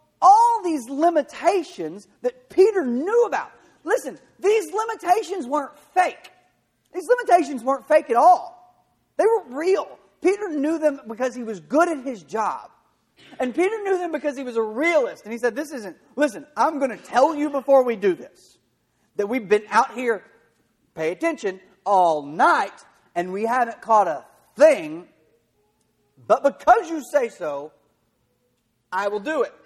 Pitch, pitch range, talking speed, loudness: 295 Hz, 230-360 Hz, 160 wpm, -21 LUFS